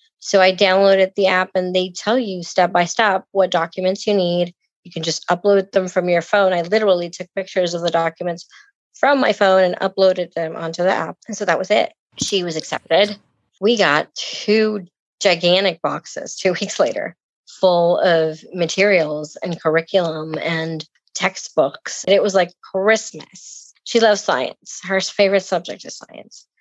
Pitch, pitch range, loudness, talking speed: 185 Hz, 175-200 Hz, -18 LUFS, 170 wpm